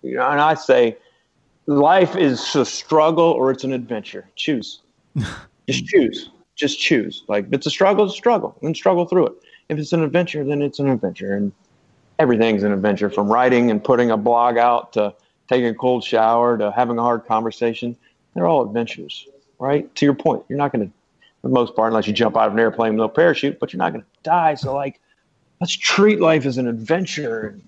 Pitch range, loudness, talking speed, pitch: 115-155 Hz, -18 LUFS, 210 wpm, 130 Hz